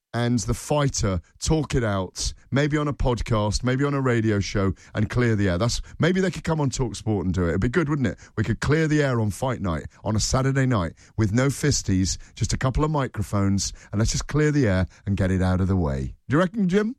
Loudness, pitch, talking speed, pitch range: -24 LUFS, 115 Hz, 255 wpm, 95-140 Hz